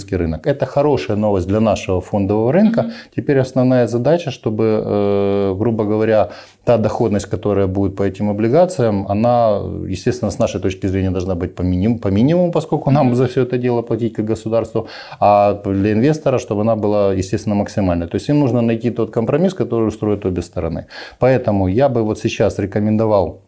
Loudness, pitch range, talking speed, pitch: -17 LUFS, 100-120 Hz, 165 wpm, 110 Hz